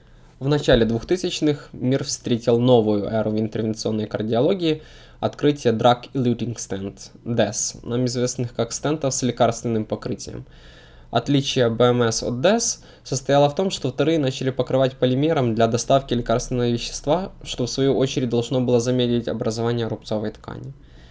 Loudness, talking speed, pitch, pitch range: -21 LUFS, 135 wpm, 120 Hz, 115-135 Hz